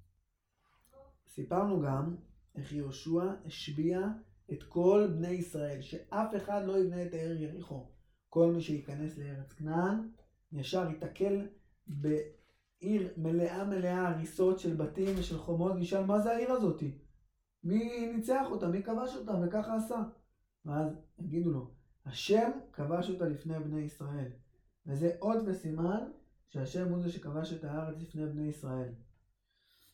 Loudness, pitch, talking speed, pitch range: -35 LUFS, 170 Hz, 130 wpm, 150-195 Hz